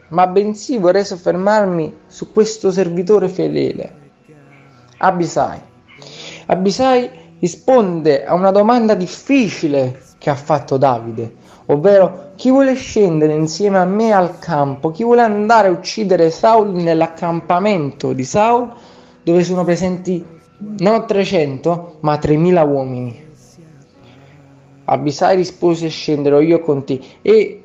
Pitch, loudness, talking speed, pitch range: 175 Hz, -15 LUFS, 115 wpm, 155-205 Hz